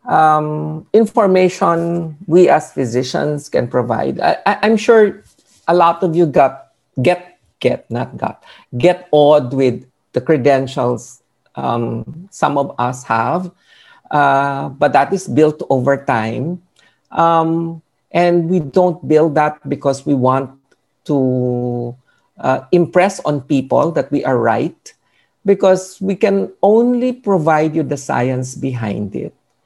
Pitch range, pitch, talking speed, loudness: 130-180 Hz, 150 Hz, 130 wpm, -15 LUFS